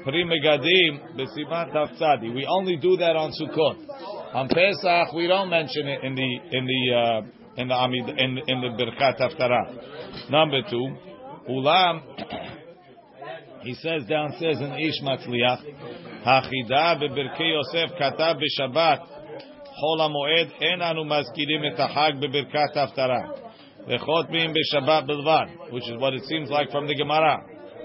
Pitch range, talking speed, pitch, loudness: 130-160 Hz, 140 wpm, 150 Hz, -23 LUFS